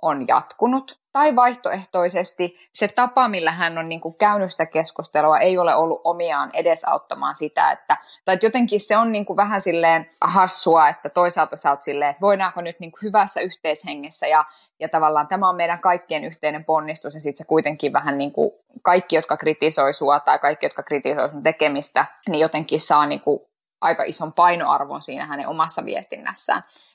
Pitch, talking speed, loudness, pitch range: 165 Hz, 170 wpm, -19 LUFS, 155-190 Hz